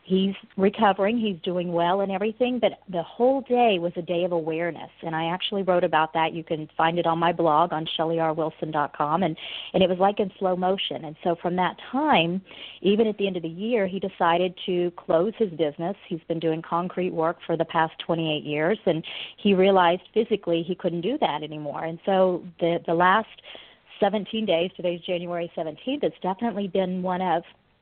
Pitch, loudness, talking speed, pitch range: 180 Hz, -25 LUFS, 195 wpm, 165-195 Hz